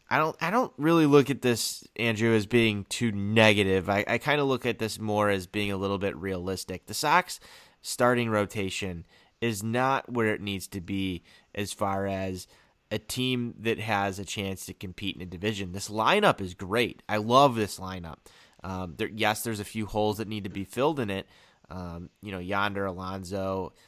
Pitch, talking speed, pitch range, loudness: 105 Hz, 200 wpm, 95-115 Hz, -27 LUFS